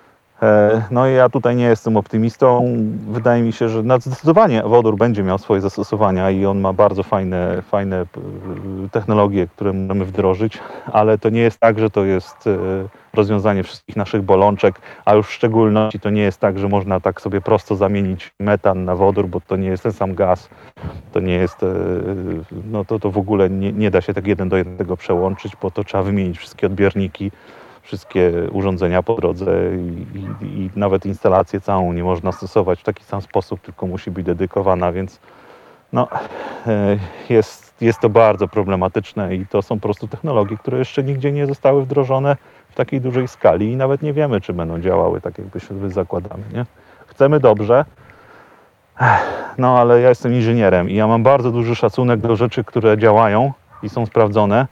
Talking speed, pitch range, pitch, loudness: 180 wpm, 95-115 Hz, 105 Hz, -17 LUFS